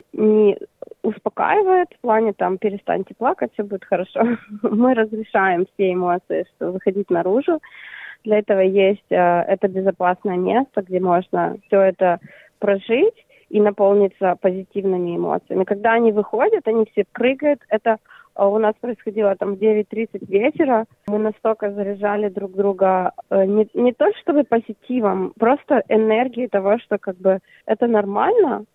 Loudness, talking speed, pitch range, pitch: -19 LUFS, 140 wpm, 195-230 Hz, 210 Hz